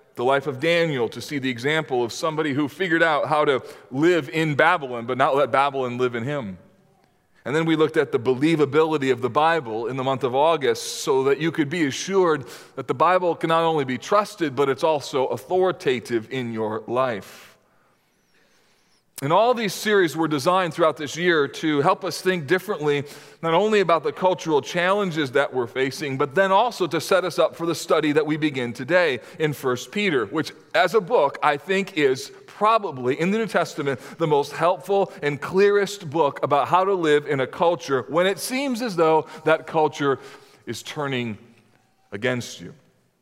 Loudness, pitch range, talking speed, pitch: -22 LUFS, 140-180 Hz, 190 wpm, 155 Hz